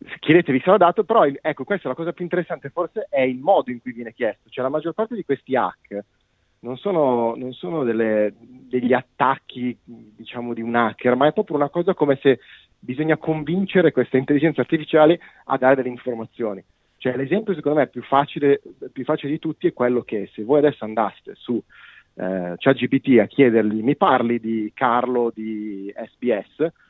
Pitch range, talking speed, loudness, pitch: 120-155 Hz, 185 wpm, -21 LUFS, 130 Hz